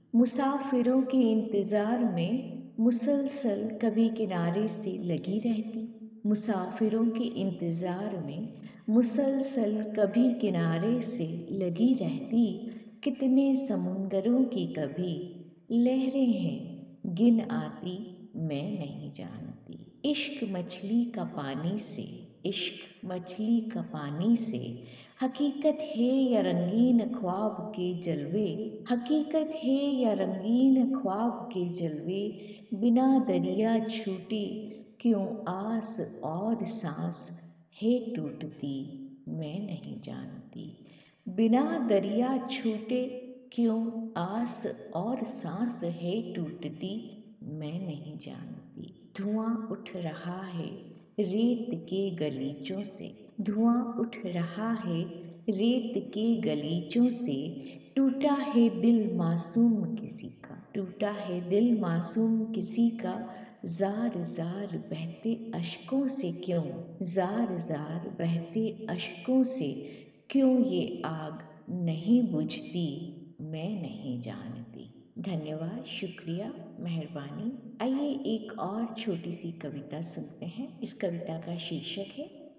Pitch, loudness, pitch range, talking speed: 215 Hz, -31 LUFS, 175-235 Hz, 105 wpm